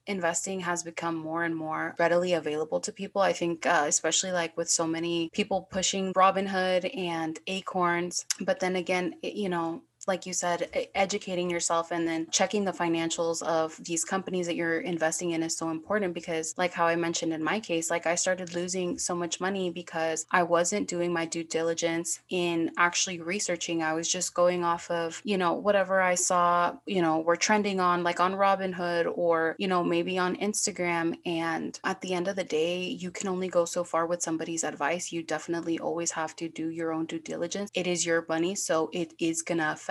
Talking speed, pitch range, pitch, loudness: 200 wpm, 165-185 Hz, 175 Hz, -28 LUFS